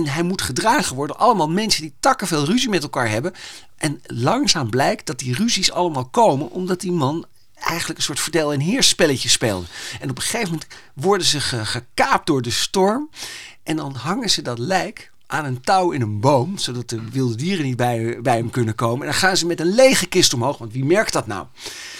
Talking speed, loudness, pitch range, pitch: 220 wpm, -19 LUFS, 125-185 Hz, 155 Hz